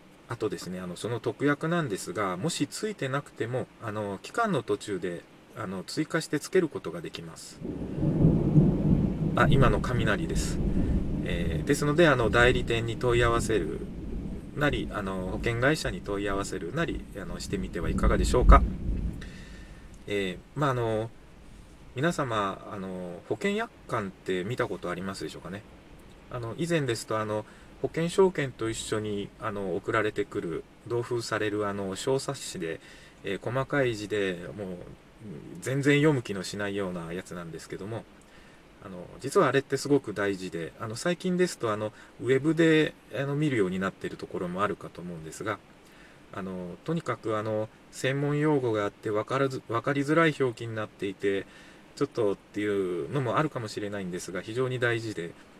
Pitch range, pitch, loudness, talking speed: 100-145 Hz, 115 Hz, -29 LUFS, 340 characters per minute